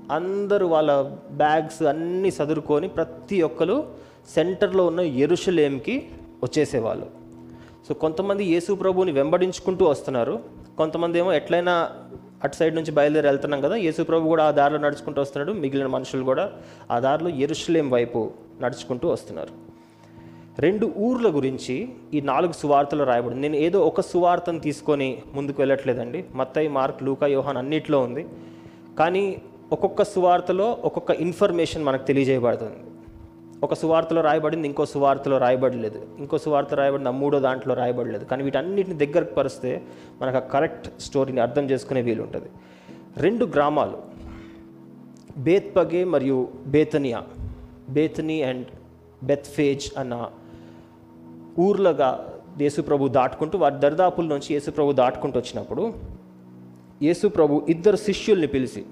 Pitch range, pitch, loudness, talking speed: 120-160 Hz, 140 Hz, -23 LUFS, 115 wpm